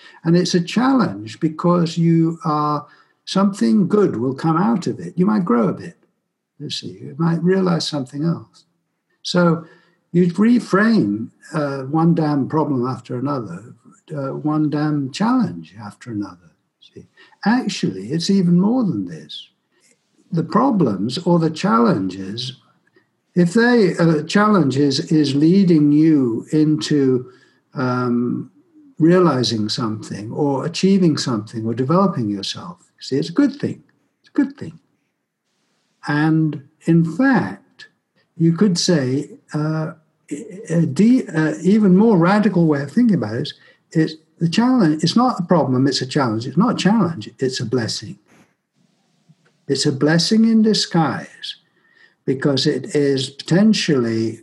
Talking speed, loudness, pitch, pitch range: 140 wpm, -18 LUFS, 165 Hz, 140-195 Hz